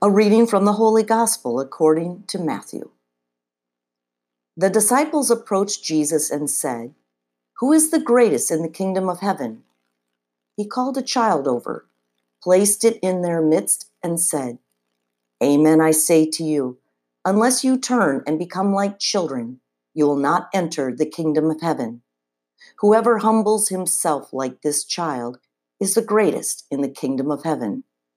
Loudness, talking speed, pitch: -19 LUFS, 150 wpm, 155 Hz